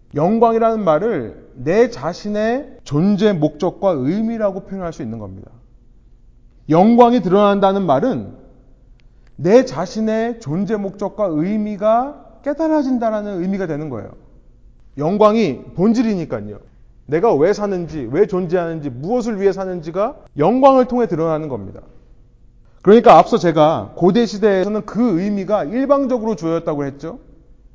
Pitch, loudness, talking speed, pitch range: 195 Hz, -16 LUFS, 300 characters per minute, 155-225 Hz